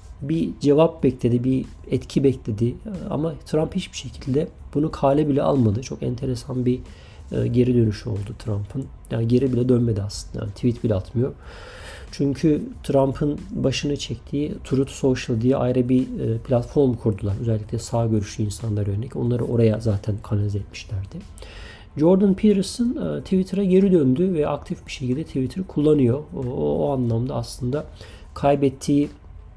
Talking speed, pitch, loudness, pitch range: 135 wpm, 125 Hz, -22 LUFS, 110-145 Hz